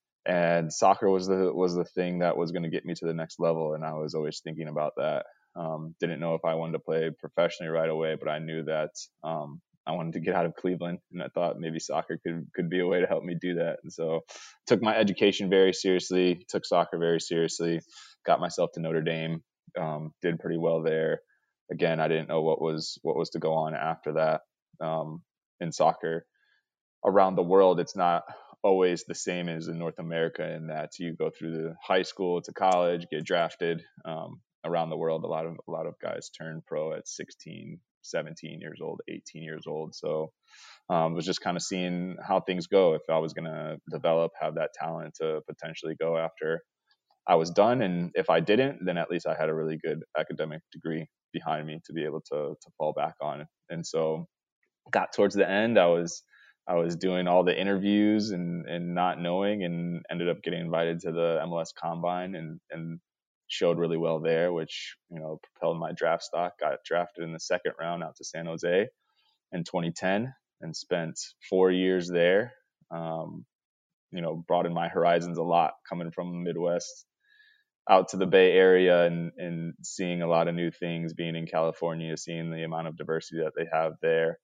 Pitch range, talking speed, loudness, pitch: 80-90 Hz, 205 wpm, -29 LUFS, 85 Hz